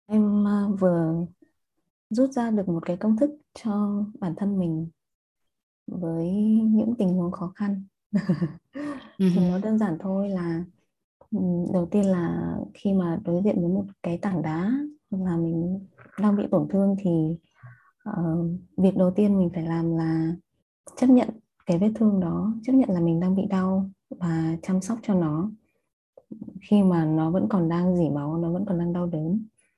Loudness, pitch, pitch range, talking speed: -25 LUFS, 190 Hz, 170-210 Hz, 170 wpm